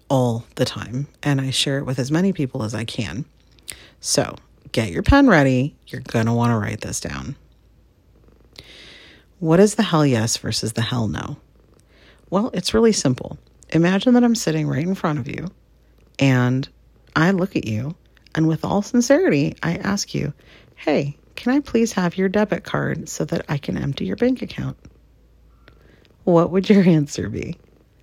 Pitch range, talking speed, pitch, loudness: 125-190 Hz, 175 wpm, 150 Hz, -20 LUFS